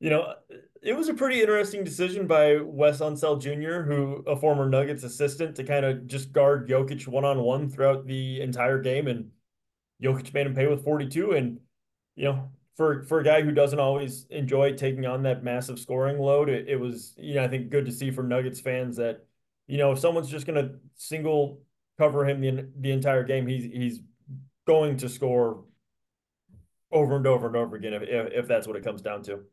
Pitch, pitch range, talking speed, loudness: 135 Hz, 130-145 Hz, 205 wpm, -26 LUFS